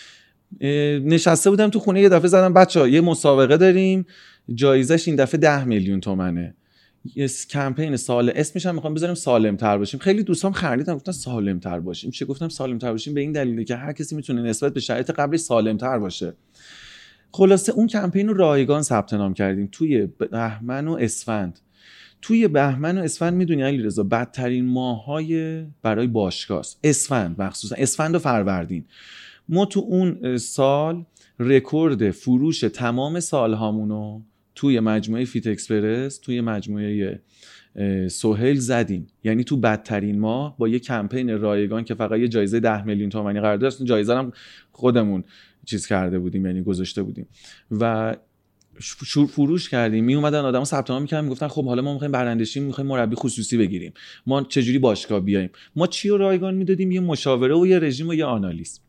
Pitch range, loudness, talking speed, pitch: 110-155 Hz, -21 LUFS, 165 wpm, 125 Hz